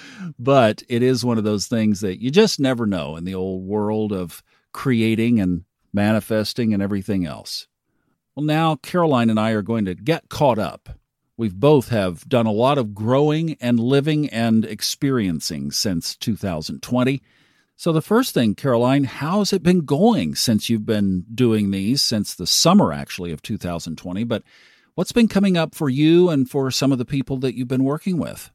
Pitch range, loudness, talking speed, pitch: 105-145 Hz, -20 LUFS, 180 wpm, 120 Hz